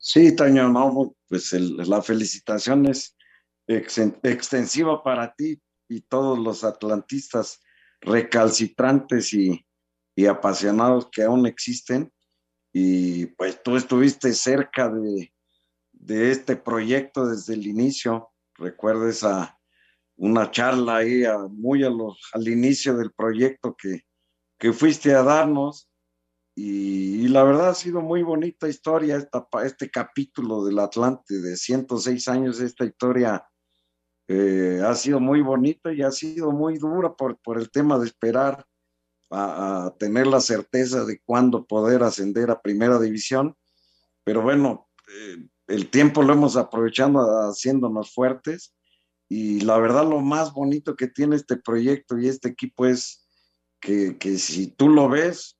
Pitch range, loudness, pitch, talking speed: 100-135 Hz, -22 LUFS, 115 Hz, 140 wpm